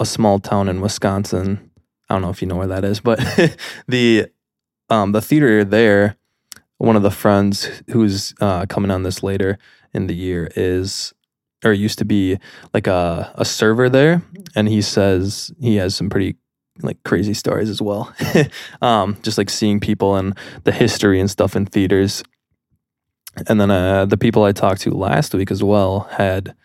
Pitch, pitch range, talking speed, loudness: 100 Hz, 95-110 Hz, 180 wpm, -17 LUFS